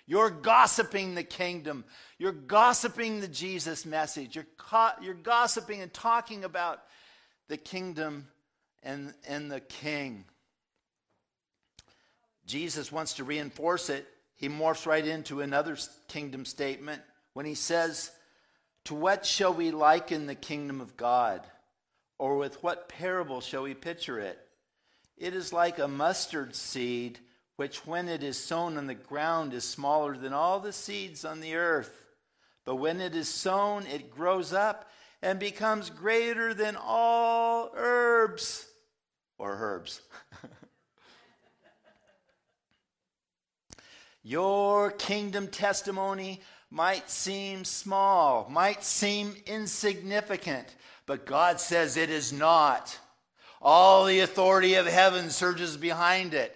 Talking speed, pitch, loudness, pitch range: 125 wpm, 175 Hz, -28 LUFS, 150-200 Hz